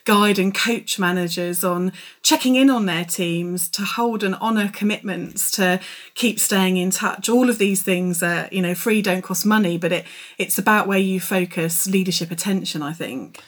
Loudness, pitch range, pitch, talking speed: -20 LUFS, 180-210 Hz, 190 Hz, 185 wpm